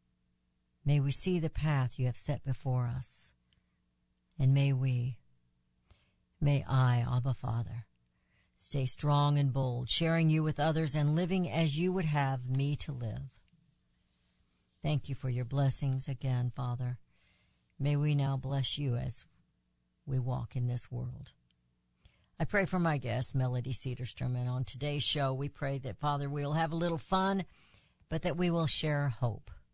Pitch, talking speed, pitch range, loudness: 130 Hz, 160 wpm, 120-145 Hz, -33 LUFS